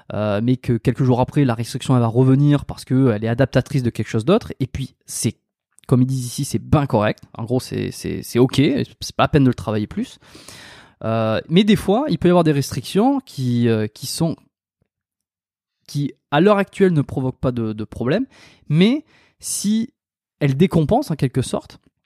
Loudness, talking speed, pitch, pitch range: -19 LUFS, 200 wpm, 130 Hz, 115-150 Hz